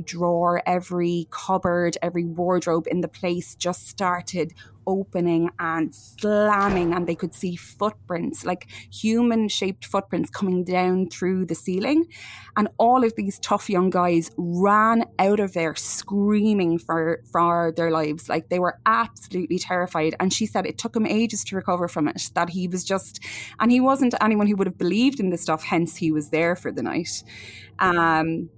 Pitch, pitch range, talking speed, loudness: 180 Hz, 170-205 Hz, 170 wpm, -23 LUFS